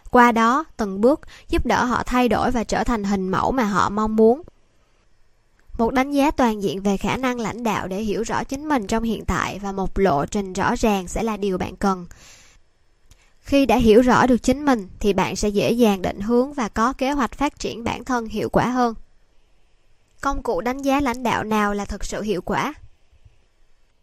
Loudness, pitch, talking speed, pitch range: -21 LUFS, 225 Hz, 210 wpm, 200-250 Hz